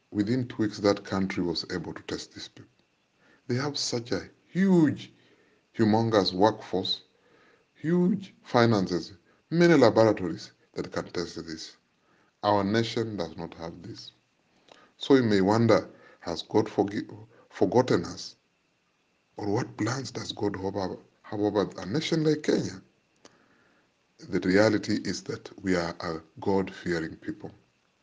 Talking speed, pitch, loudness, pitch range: 135 wpm, 105 Hz, -27 LUFS, 95-120 Hz